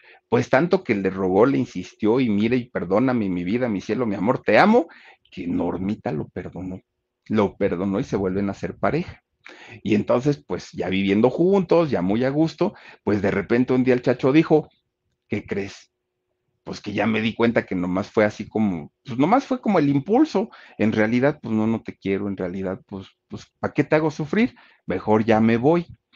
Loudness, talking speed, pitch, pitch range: -22 LUFS, 200 wpm, 115 Hz, 95-150 Hz